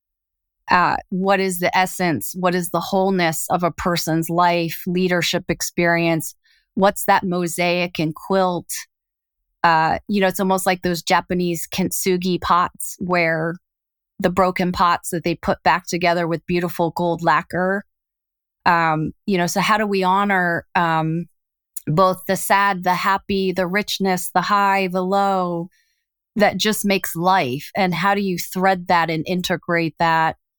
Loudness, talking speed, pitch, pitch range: -19 LUFS, 145 wpm, 180 Hz, 170-190 Hz